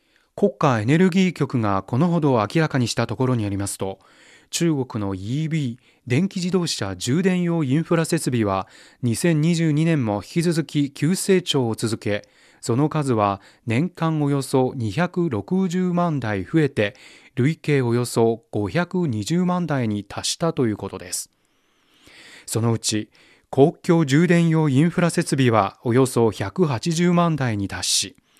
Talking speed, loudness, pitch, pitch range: 245 characters per minute, -21 LUFS, 140 Hz, 115-170 Hz